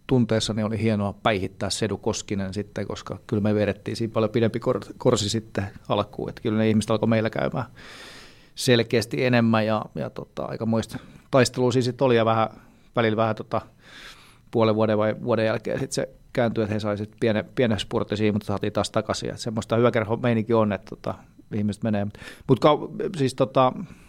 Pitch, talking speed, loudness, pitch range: 110 Hz, 170 wpm, -24 LUFS, 105-120 Hz